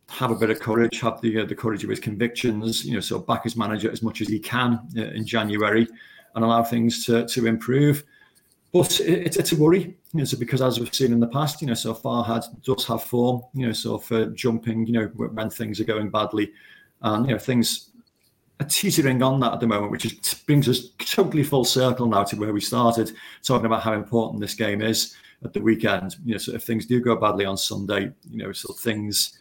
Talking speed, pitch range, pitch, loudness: 240 wpm, 110-125 Hz, 115 Hz, -23 LUFS